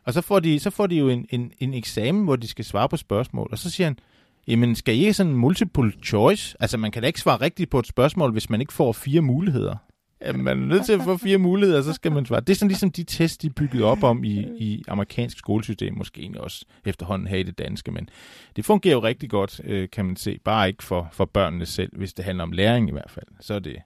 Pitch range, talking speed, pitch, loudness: 100-165 Hz, 270 wpm, 120 Hz, -23 LUFS